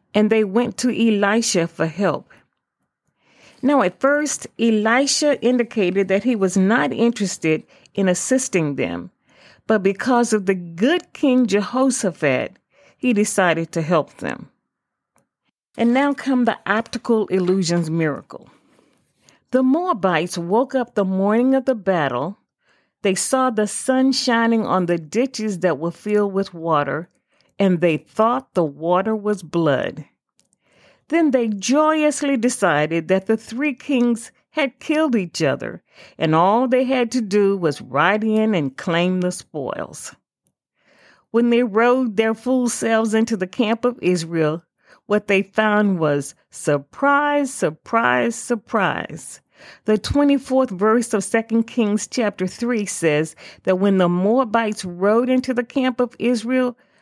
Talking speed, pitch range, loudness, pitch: 140 wpm, 185-250 Hz, -19 LUFS, 220 Hz